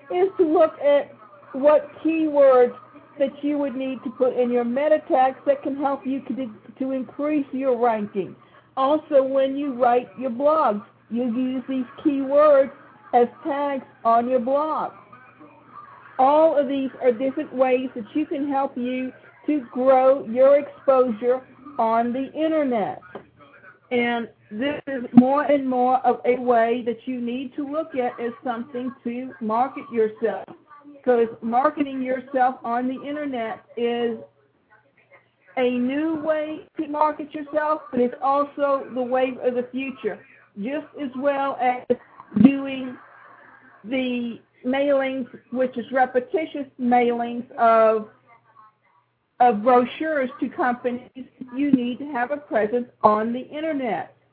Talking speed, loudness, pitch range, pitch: 135 wpm, -22 LUFS, 245-285 Hz, 260 Hz